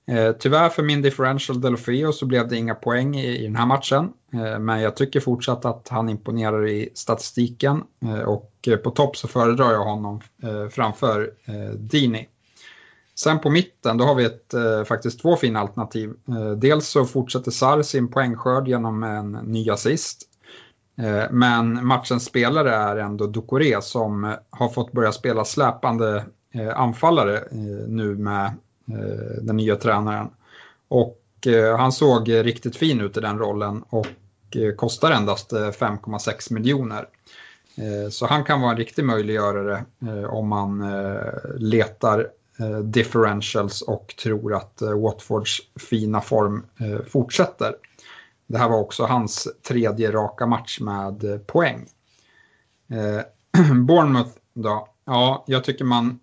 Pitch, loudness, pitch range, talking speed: 115 Hz, -22 LUFS, 105-125 Hz, 140 wpm